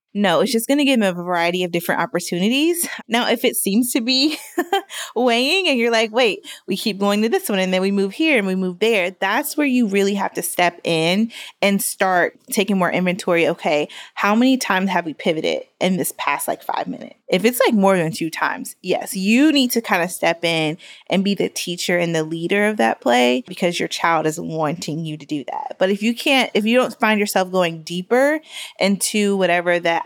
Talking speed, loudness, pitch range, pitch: 225 wpm, -19 LUFS, 175-245 Hz, 200 Hz